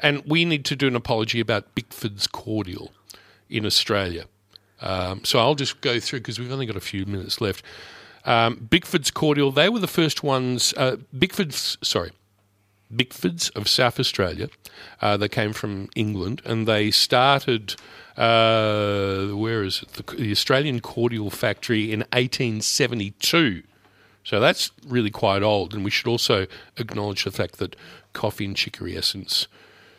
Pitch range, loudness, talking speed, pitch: 100-130 Hz, -22 LUFS, 155 wpm, 115 Hz